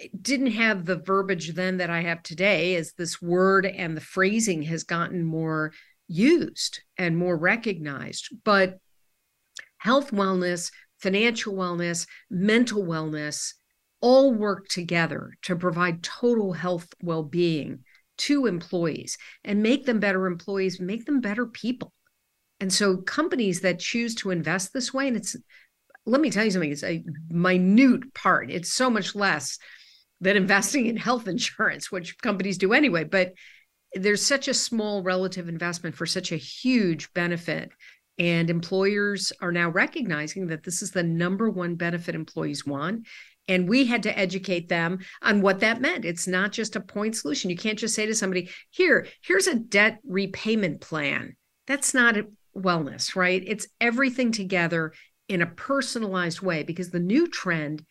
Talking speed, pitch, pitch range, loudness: 155 wpm, 190 Hz, 175-220 Hz, -25 LUFS